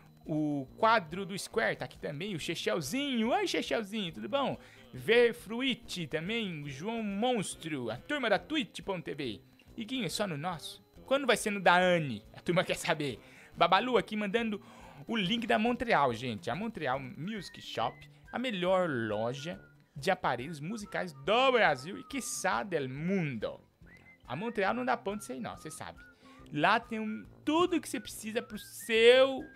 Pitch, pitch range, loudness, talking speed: 195 Hz, 155-230 Hz, -32 LUFS, 165 wpm